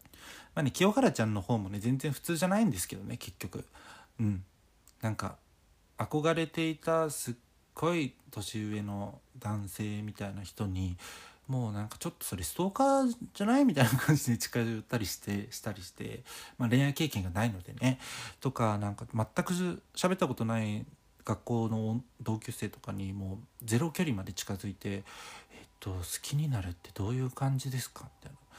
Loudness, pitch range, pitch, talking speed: -33 LUFS, 100-140 Hz, 115 Hz, 350 characters per minute